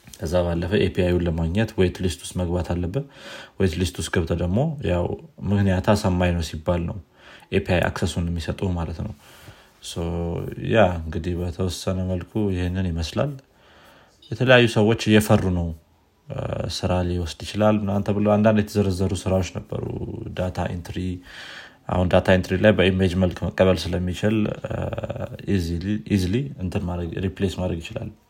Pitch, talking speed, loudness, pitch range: 95 Hz, 120 wpm, -23 LUFS, 90-105 Hz